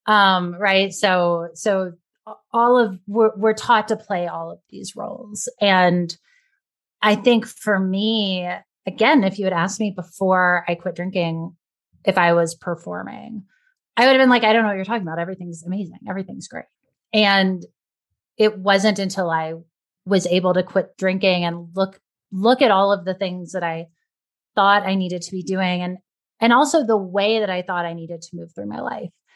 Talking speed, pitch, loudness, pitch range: 185 wpm, 190 Hz, -19 LUFS, 175-215 Hz